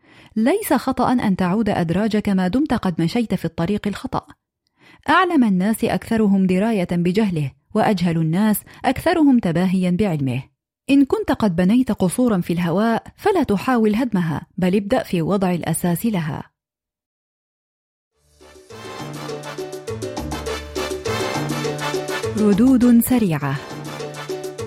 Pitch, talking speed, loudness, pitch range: 195 Hz, 95 wpm, -19 LUFS, 165-230 Hz